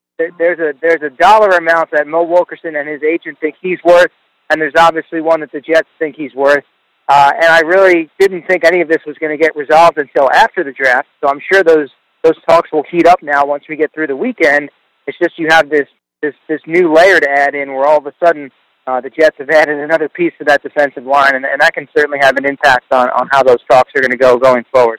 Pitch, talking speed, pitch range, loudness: 155 Hz, 255 wpm, 145-165 Hz, -11 LUFS